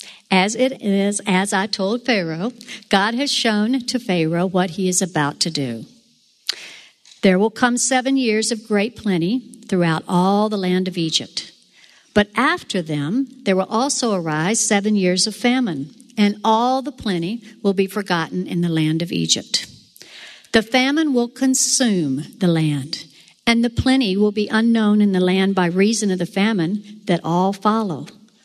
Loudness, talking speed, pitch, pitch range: -19 LUFS, 165 wpm, 205 Hz, 180-235 Hz